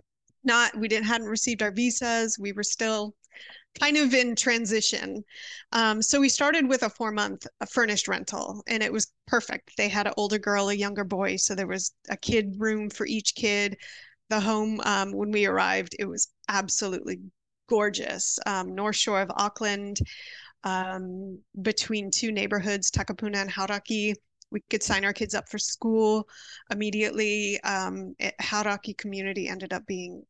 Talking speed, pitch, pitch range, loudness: 165 wpm, 210 Hz, 200-225 Hz, -26 LUFS